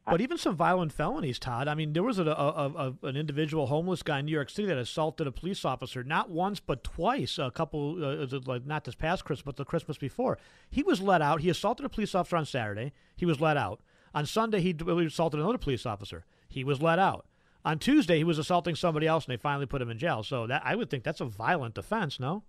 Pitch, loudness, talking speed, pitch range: 155 Hz, -30 LUFS, 250 wpm, 140-175 Hz